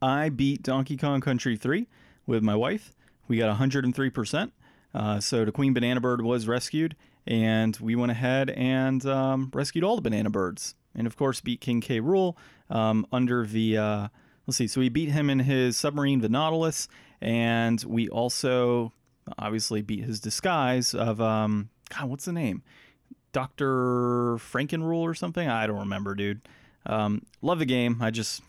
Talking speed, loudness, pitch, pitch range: 170 wpm, -27 LUFS, 125 Hz, 110-135 Hz